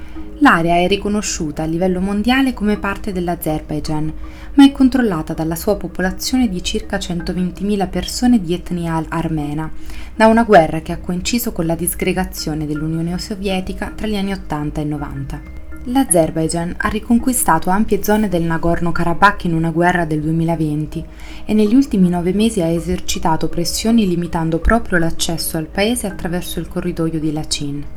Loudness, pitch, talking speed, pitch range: -17 LUFS, 175 Hz, 150 wpm, 160-205 Hz